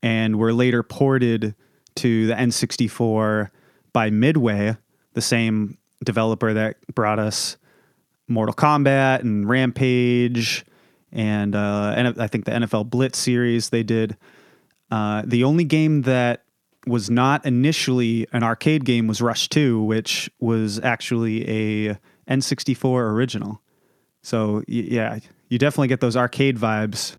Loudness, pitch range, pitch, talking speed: -21 LUFS, 110-125 Hz, 115 Hz, 130 wpm